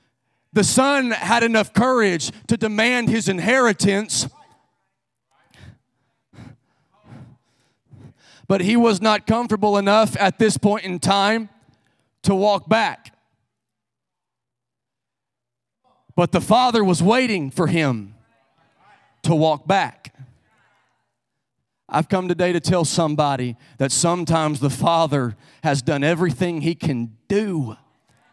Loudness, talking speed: -19 LUFS, 105 wpm